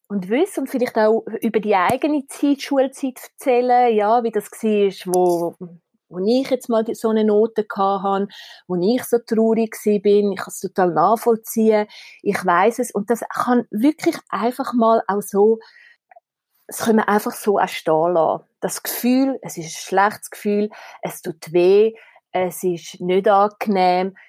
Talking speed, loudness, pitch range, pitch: 155 wpm, -19 LUFS, 195-240 Hz, 215 Hz